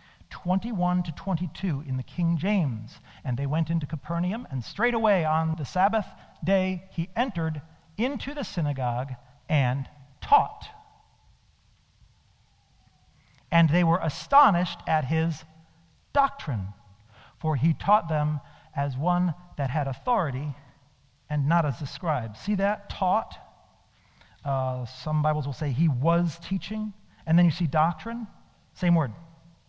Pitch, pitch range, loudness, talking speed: 160 Hz, 135-180 Hz, -27 LUFS, 130 wpm